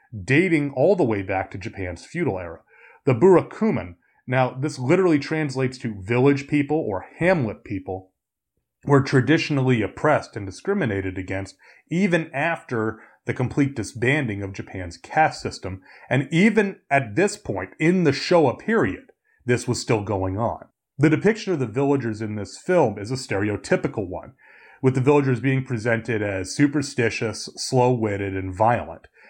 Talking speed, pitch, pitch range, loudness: 145 wpm, 130 Hz, 105-150 Hz, -22 LUFS